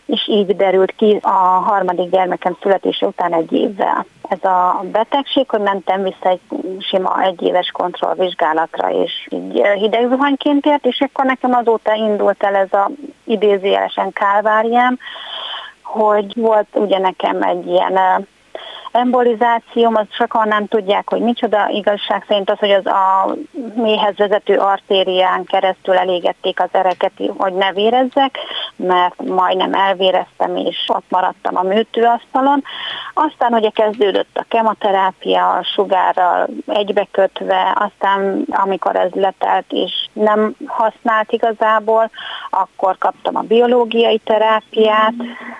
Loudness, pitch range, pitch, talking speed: -15 LUFS, 190-230 Hz, 210 Hz, 120 wpm